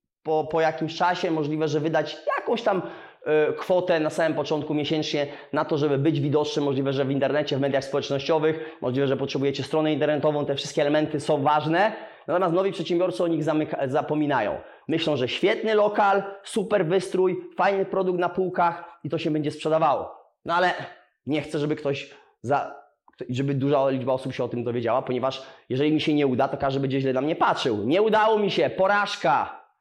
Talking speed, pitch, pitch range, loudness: 185 wpm, 155 Hz, 140-175 Hz, -24 LUFS